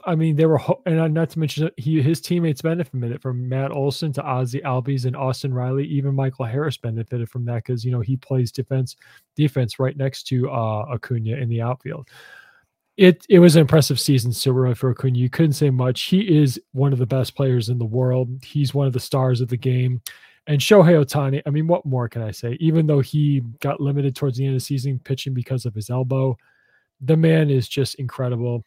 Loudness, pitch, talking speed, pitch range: -20 LUFS, 135 Hz, 225 wpm, 125-150 Hz